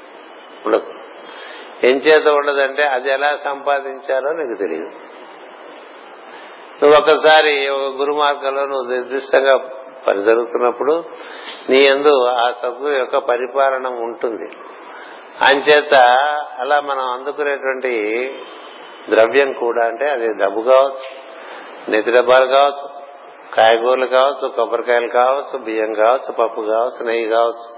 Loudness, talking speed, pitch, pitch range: -16 LUFS, 100 wpm, 135 Hz, 125-145 Hz